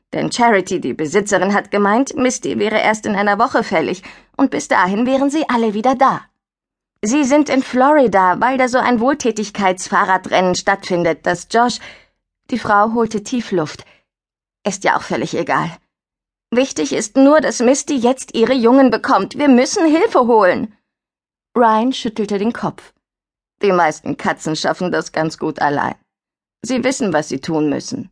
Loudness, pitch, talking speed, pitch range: -16 LUFS, 230 Hz, 155 wpm, 195-260 Hz